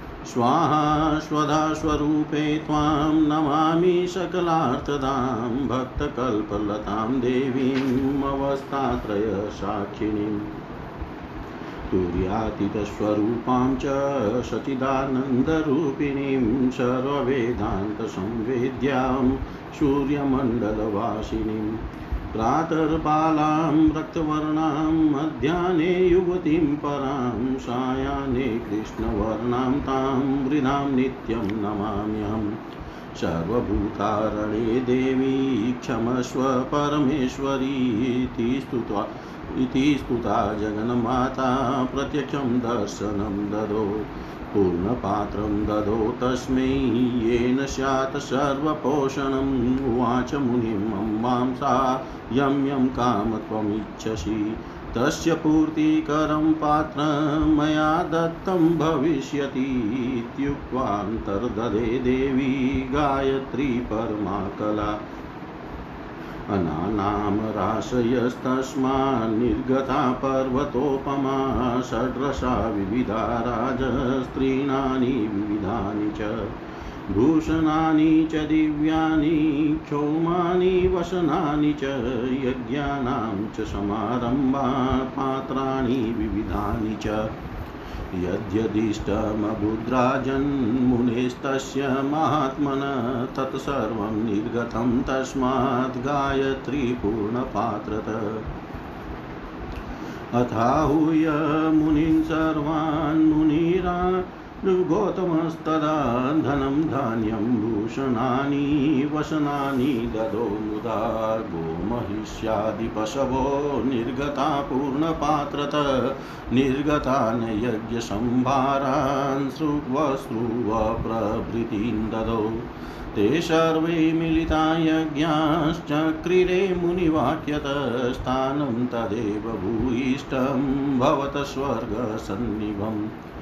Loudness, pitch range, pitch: -24 LUFS, 110-145 Hz, 130 Hz